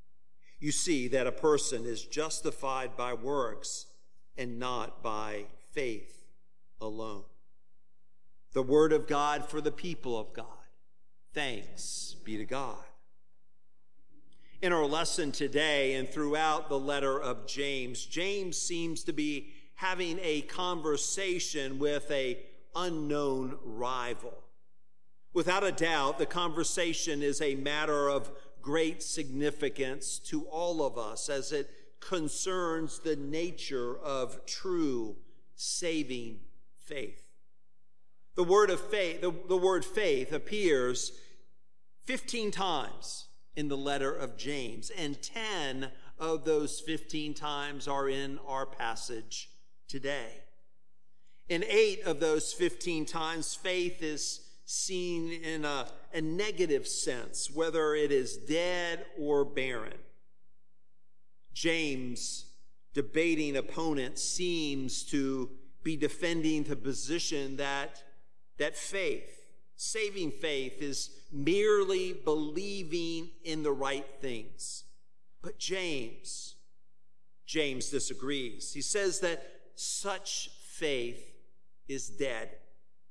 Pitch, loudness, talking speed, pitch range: 150 Hz, -33 LUFS, 110 wpm, 130-170 Hz